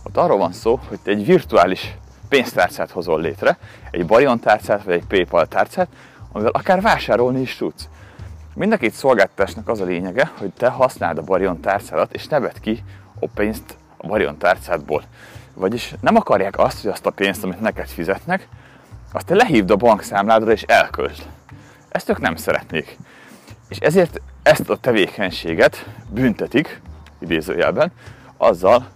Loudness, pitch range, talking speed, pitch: -18 LUFS, 90-115 Hz, 155 wpm, 100 Hz